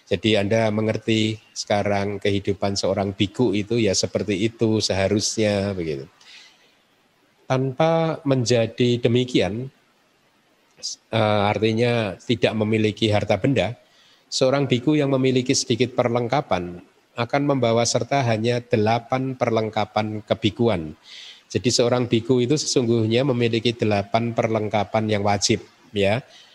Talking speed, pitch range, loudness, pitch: 100 wpm, 105-125 Hz, -22 LUFS, 115 Hz